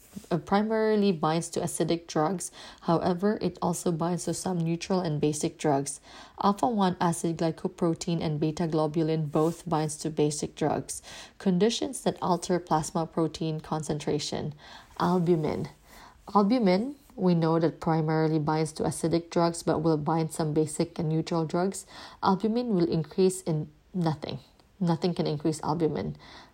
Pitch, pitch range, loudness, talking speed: 170 Hz, 160-185 Hz, -28 LUFS, 135 wpm